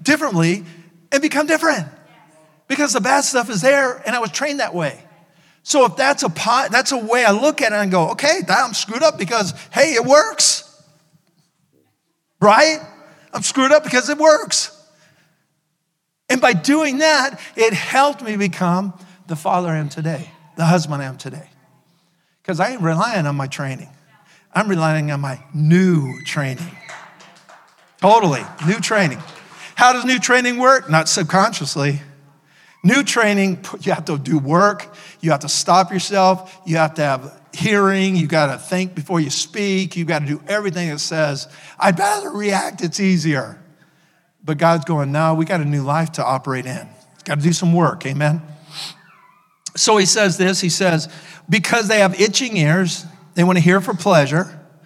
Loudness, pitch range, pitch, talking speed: -17 LUFS, 155-210 Hz, 175 Hz, 175 wpm